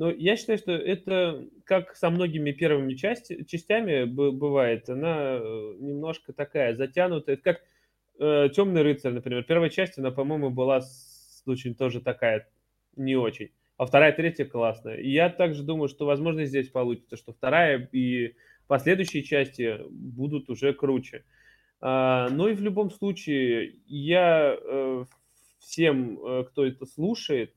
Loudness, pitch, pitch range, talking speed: -26 LUFS, 140 Hz, 130-170 Hz, 140 wpm